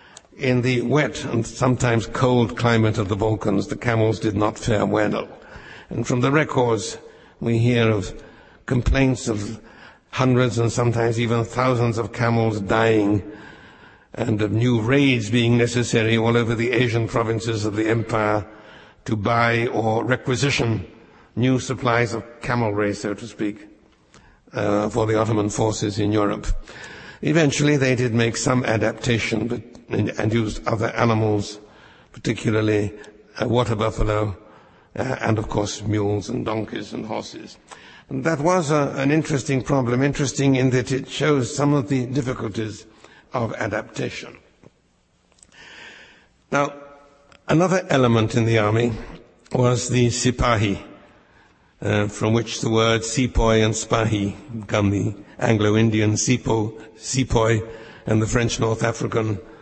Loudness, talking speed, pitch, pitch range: -21 LUFS, 135 wpm, 115 Hz, 110-125 Hz